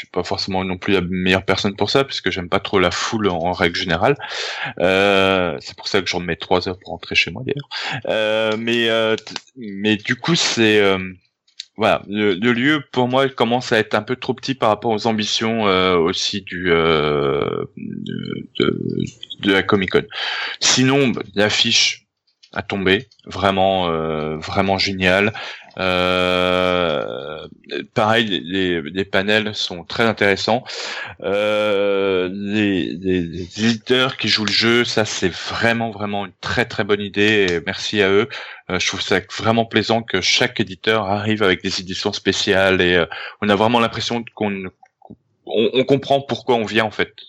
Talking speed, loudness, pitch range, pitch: 175 wpm, -18 LUFS, 95-115 Hz, 105 Hz